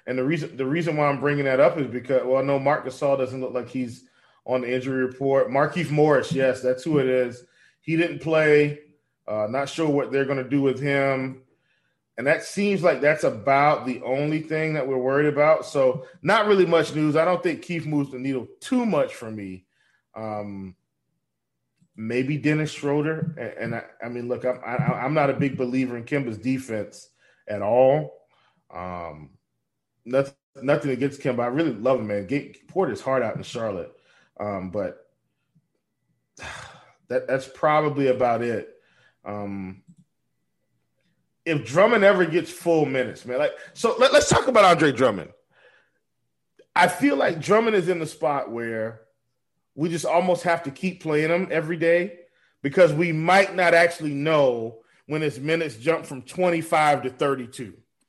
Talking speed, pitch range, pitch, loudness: 175 wpm, 130-165 Hz, 145 Hz, -23 LUFS